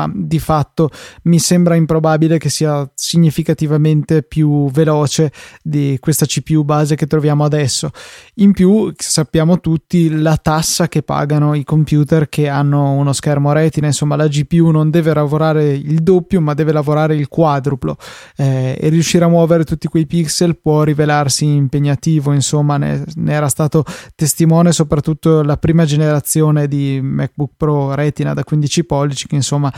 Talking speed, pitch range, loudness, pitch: 150 wpm, 145-160 Hz, -14 LUFS, 155 Hz